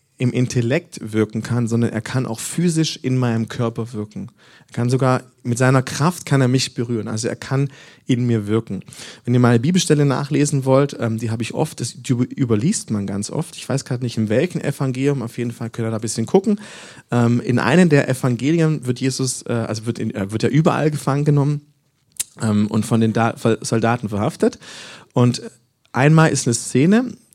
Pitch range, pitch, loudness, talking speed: 115-145 Hz, 125 Hz, -19 LUFS, 185 wpm